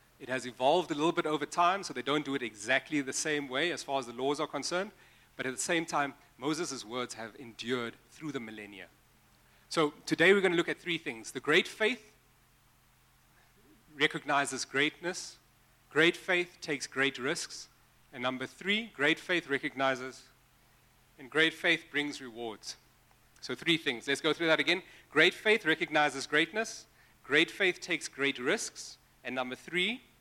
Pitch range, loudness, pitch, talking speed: 130-165 Hz, -31 LUFS, 145 Hz, 170 wpm